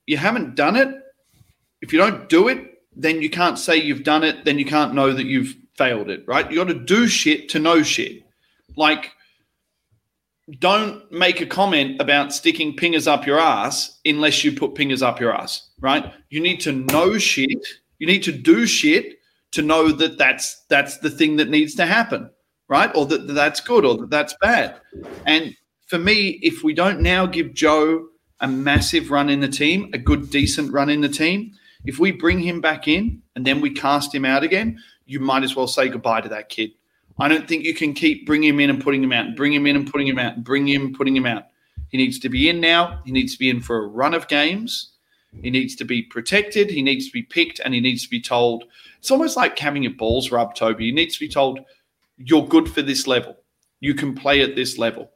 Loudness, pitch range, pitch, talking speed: -19 LUFS, 135-190 Hz, 150 Hz, 230 wpm